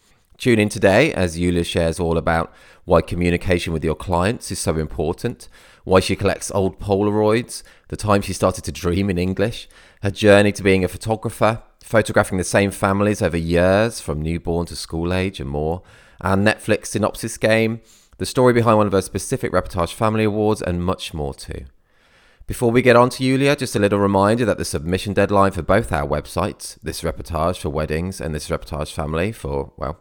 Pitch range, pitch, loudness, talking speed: 85-105 Hz, 95 Hz, -19 LUFS, 190 wpm